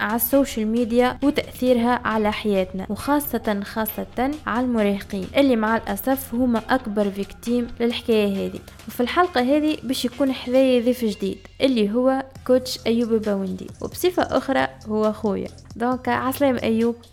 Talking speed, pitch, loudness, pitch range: 135 wpm, 235 Hz, -22 LUFS, 210-255 Hz